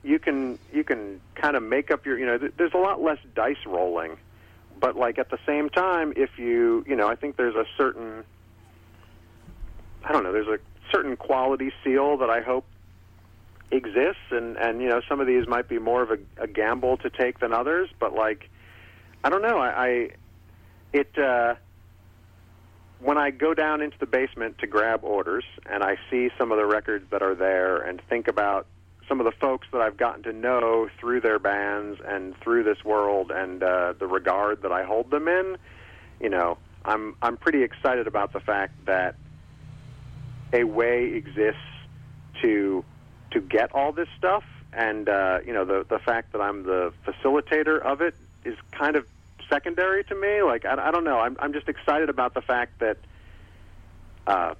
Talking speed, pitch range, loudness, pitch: 190 wpm, 95-135 Hz, -25 LUFS, 115 Hz